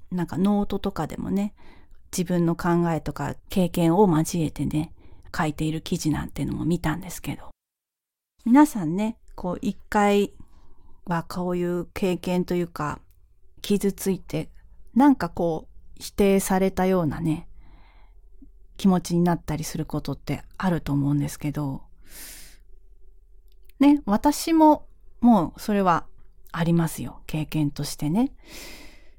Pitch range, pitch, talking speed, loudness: 150-195 Hz, 170 Hz, 255 characters per minute, -24 LUFS